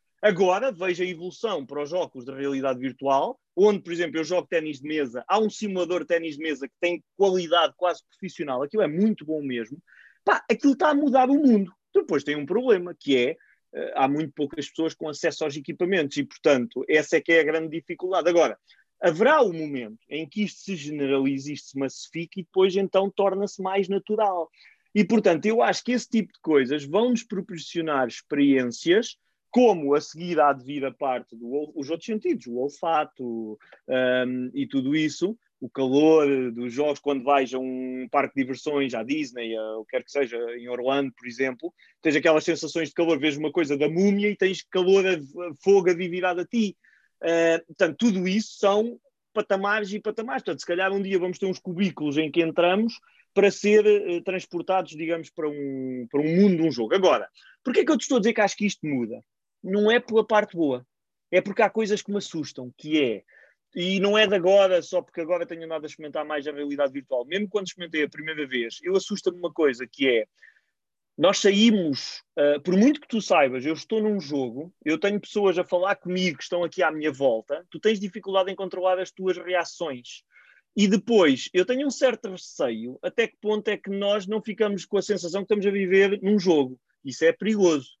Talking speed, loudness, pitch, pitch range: 200 wpm, -24 LUFS, 175 Hz, 145-205 Hz